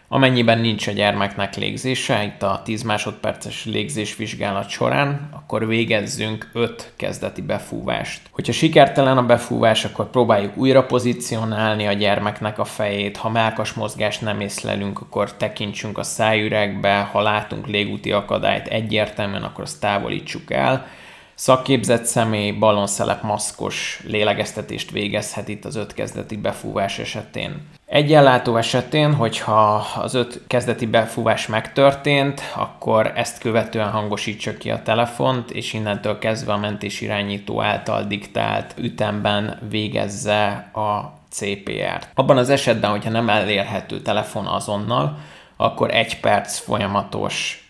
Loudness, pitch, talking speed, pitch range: -20 LUFS, 110 Hz, 125 wpm, 105-120 Hz